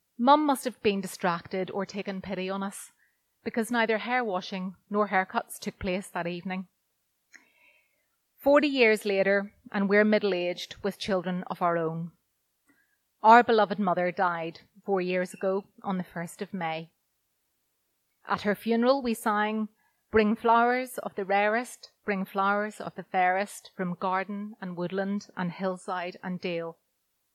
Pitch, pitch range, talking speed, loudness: 200 Hz, 185-220 Hz, 145 wpm, -28 LUFS